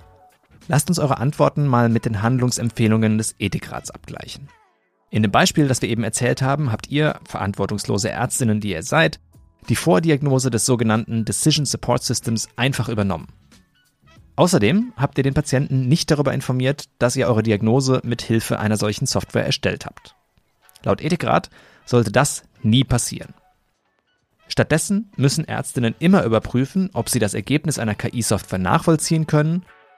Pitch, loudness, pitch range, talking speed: 125 Hz, -20 LUFS, 110-145 Hz, 145 wpm